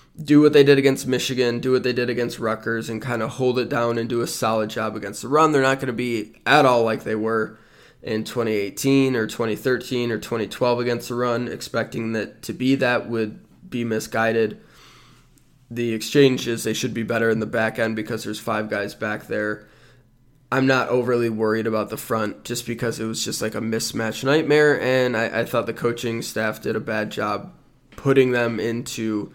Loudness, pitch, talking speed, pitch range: -22 LUFS, 115 Hz, 200 wpm, 110-125 Hz